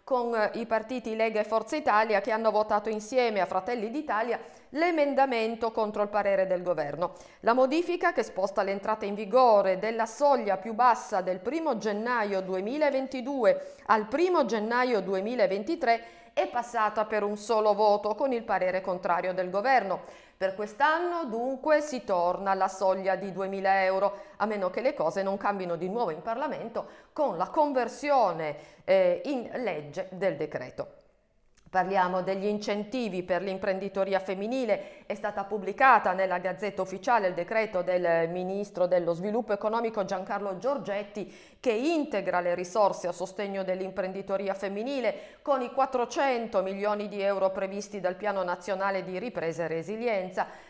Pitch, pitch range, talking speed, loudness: 205 Hz, 190-240 Hz, 145 wpm, -28 LUFS